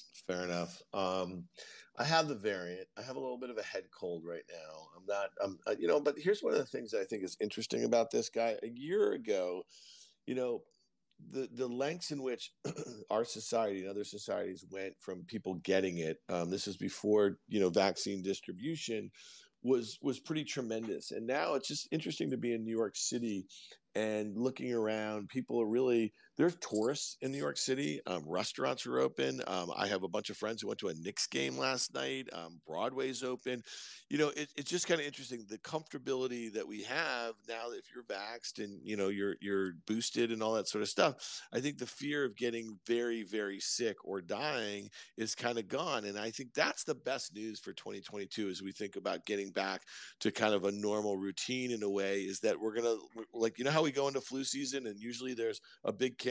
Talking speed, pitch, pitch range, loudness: 215 wpm, 110 Hz, 100-130 Hz, -37 LUFS